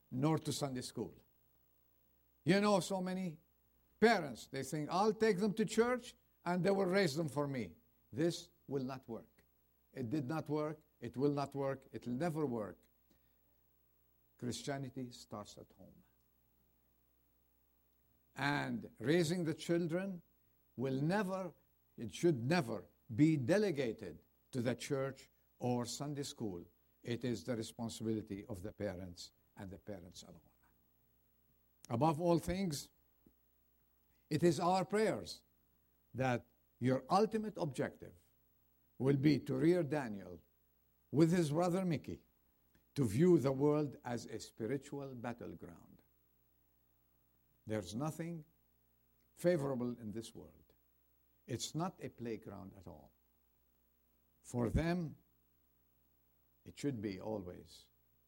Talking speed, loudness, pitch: 120 wpm, -38 LUFS, 110 Hz